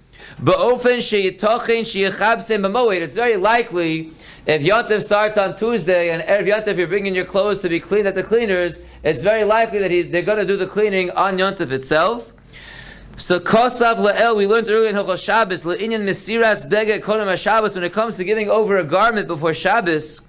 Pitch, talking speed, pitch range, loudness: 200 Hz, 170 wpm, 180-220 Hz, -17 LUFS